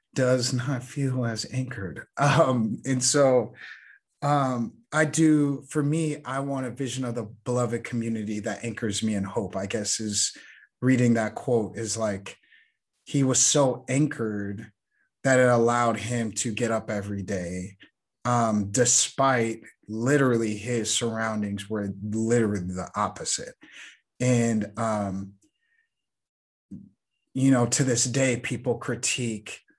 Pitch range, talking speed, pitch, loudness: 110-130 Hz, 130 wpm, 120 Hz, -25 LUFS